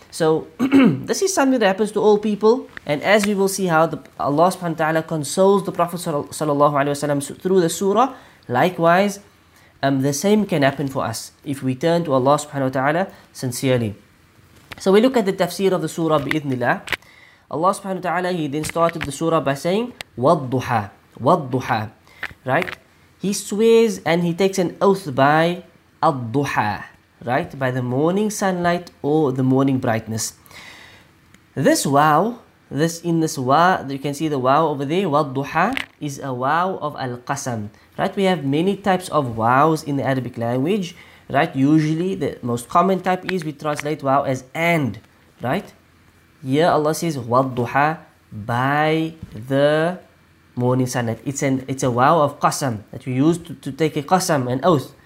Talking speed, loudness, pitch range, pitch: 170 wpm, -20 LUFS, 130-175 Hz, 150 Hz